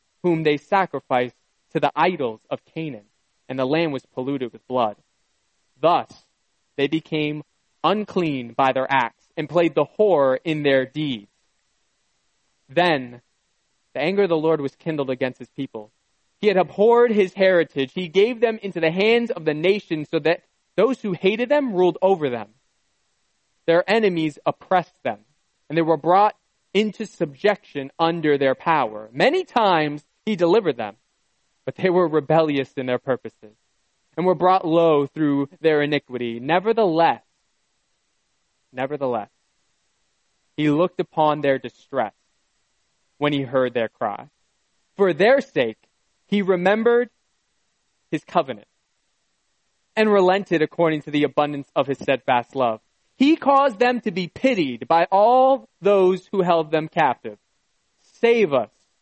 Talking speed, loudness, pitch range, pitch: 140 wpm, -21 LUFS, 140-195 Hz, 165 Hz